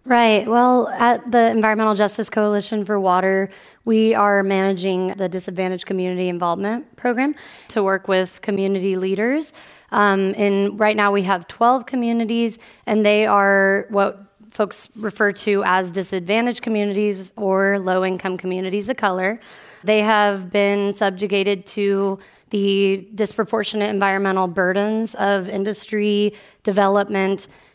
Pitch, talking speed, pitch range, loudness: 205 Hz, 125 wpm, 195-215 Hz, -19 LUFS